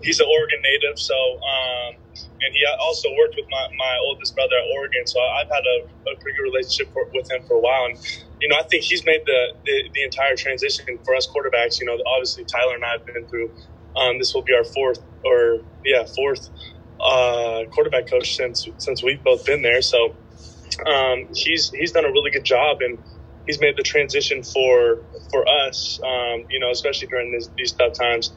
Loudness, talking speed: -20 LUFS, 210 wpm